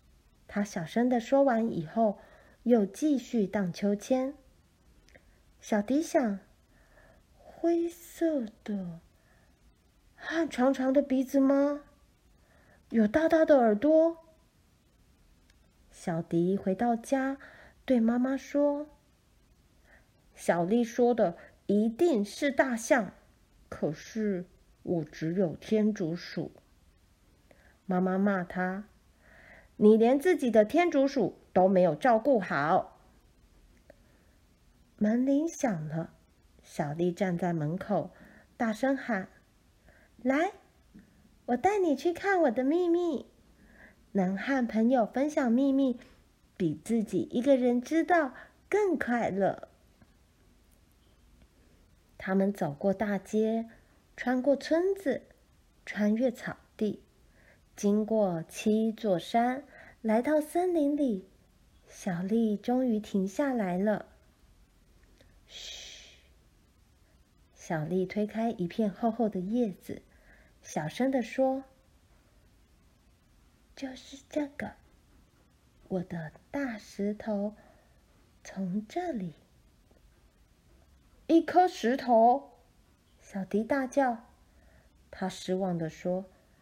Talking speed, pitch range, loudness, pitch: 135 characters per minute, 180-270 Hz, -29 LUFS, 220 Hz